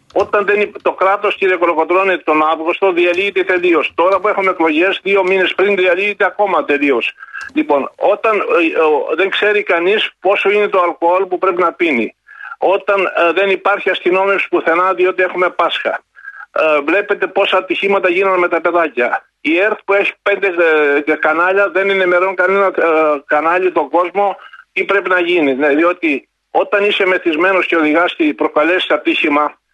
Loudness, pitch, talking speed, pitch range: -13 LUFS, 185 Hz, 165 wpm, 170-200 Hz